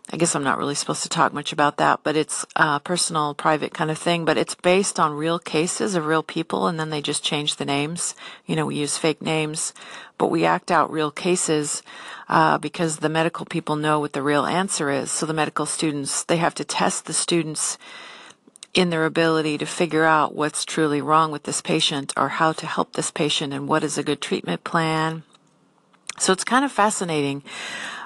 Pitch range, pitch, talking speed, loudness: 150-165 Hz, 155 Hz, 210 wpm, -22 LUFS